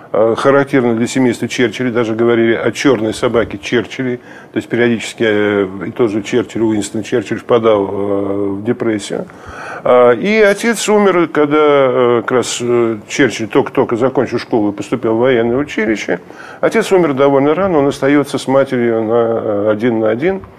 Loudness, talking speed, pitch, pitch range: -14 LUFS, 145 wpm, 120 Hz, 110-140 Hz